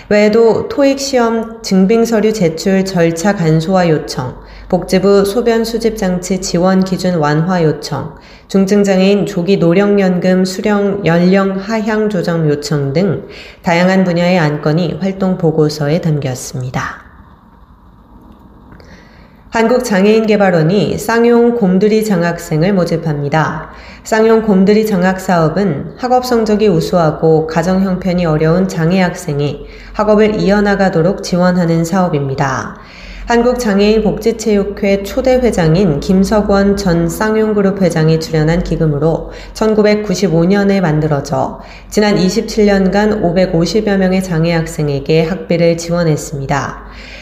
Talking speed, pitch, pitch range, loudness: 270 characters per minute, 185 Hz, 165-210 Hz, -12 LUFS